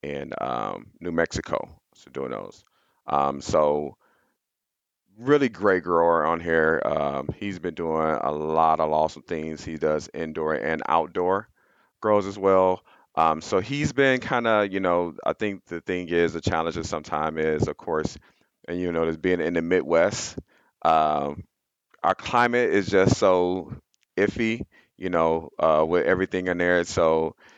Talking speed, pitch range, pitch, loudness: 165 wpm, 80-95 Hz, 85 Hz, -24 LUFS